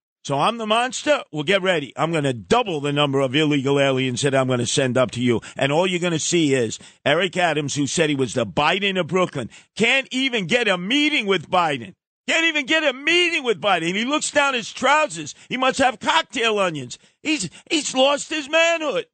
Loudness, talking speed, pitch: -20 LUFS, 220 wpm, 195 Hz